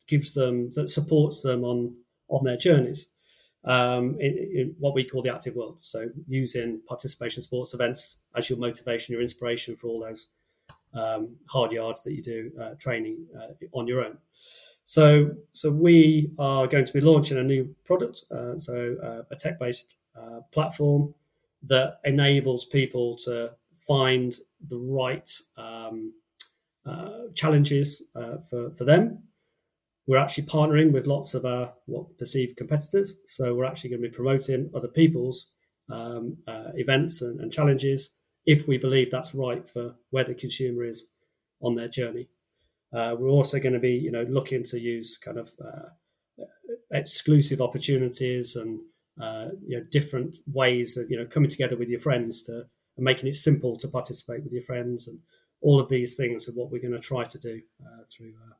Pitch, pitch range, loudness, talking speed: 130 Hz, 120-145 Hz, -25 LUFS, 170 wpm